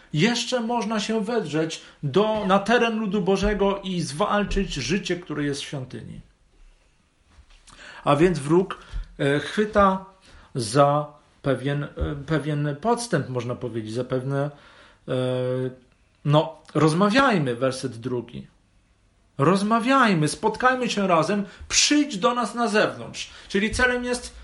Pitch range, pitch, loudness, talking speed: 135-210 Hz, 160 Hz, -23 LUFS, 115 wpm